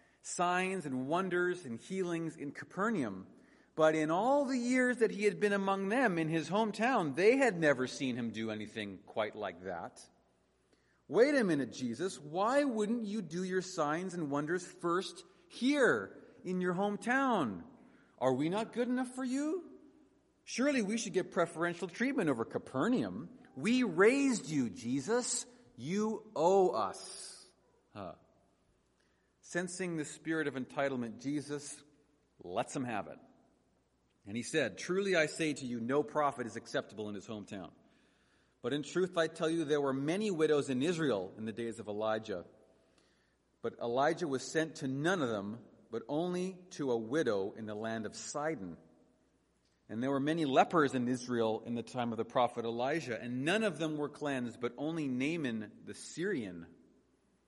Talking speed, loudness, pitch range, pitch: 165 wpm, -35 LUFS, 130-210 Hz, 160 Hz